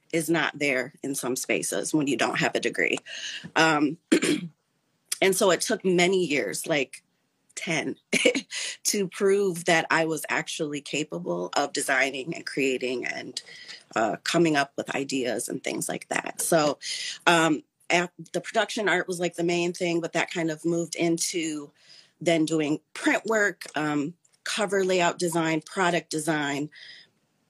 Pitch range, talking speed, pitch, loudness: 150-175 Hz, 150 wpm, 165 Hz, -26 LUFS